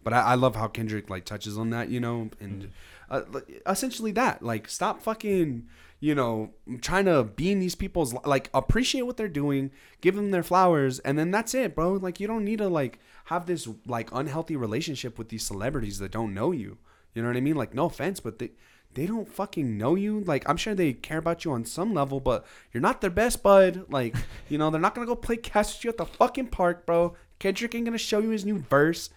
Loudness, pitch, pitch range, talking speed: -27 LUFS, 160 Hz, 120-195 Hz, 235 wpm